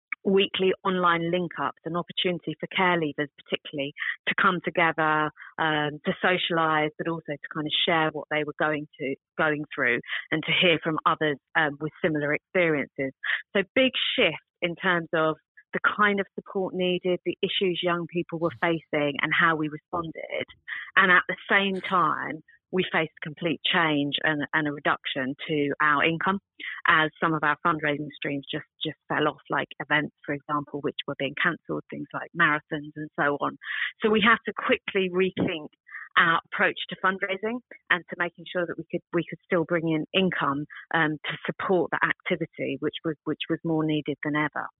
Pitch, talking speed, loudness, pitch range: 165 Hz, 180 wpm, -26 LUFS, 150-180 Hz